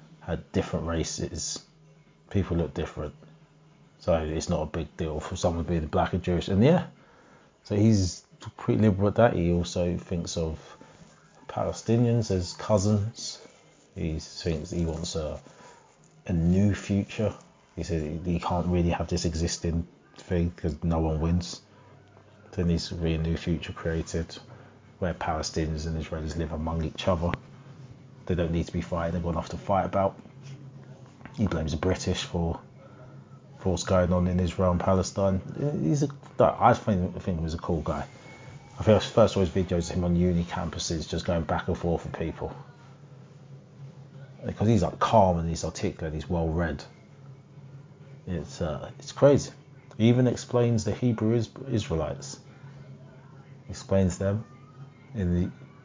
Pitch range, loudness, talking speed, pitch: 85-130 Hz, -28 LUFS, 160 wpm, 95 Hz